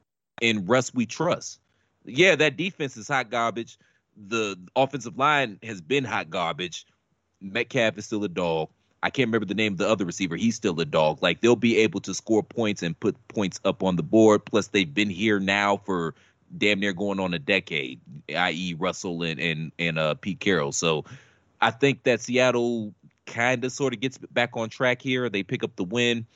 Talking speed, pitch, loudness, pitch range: 200 wpm, 110 Hz, -25 LUFS, 95-120 Hz